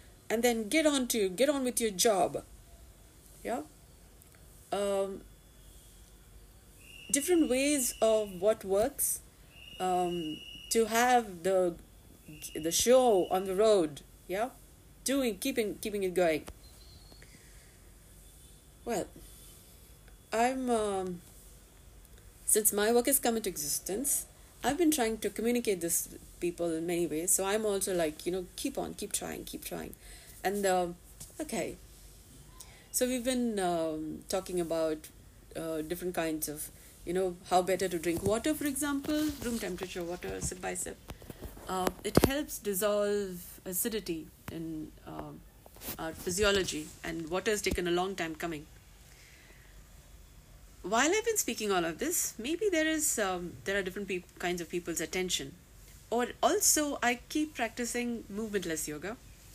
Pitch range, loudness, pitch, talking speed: 170-240 Hz, -31 LUFS, 195 Hz, 135 wpm